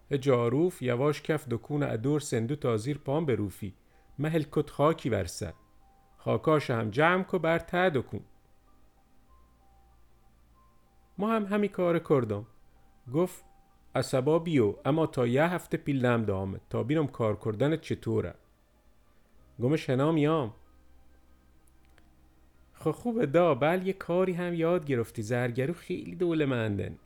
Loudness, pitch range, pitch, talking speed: -29 LUFS, 105-160 Hz, 130 Hz, 125 wpm